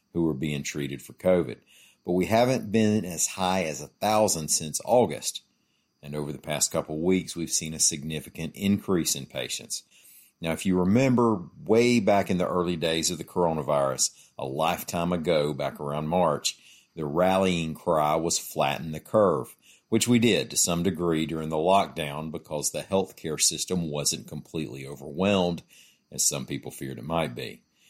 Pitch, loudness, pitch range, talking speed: 80 Hz, -26 LUFS, 75-95 Hz, 170 wpm